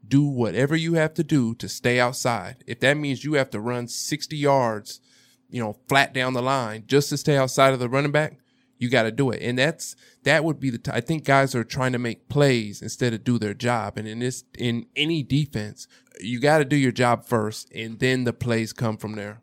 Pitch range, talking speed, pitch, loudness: 115-140 Hz, 240 wpm, 125 Hz, -23 LUFS